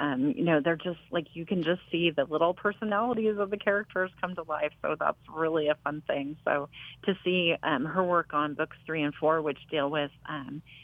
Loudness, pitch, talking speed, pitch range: -29 LUFS, 160 Hz, 220 wpm, 150-185 Hz